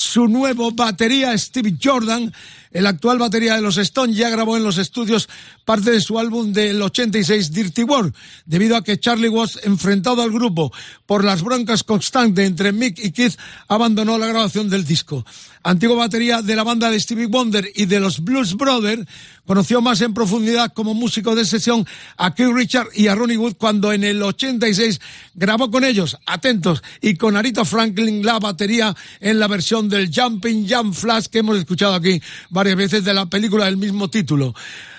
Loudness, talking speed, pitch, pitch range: -17 LUFS, 180 wpm, 220 Hz, 200-235 Hz